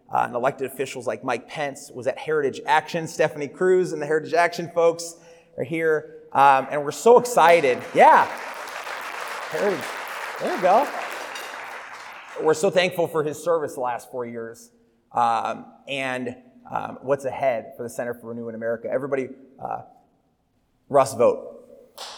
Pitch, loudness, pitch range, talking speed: 155 Hz, -23 LUFS, 130-170 Hz, 155 wpm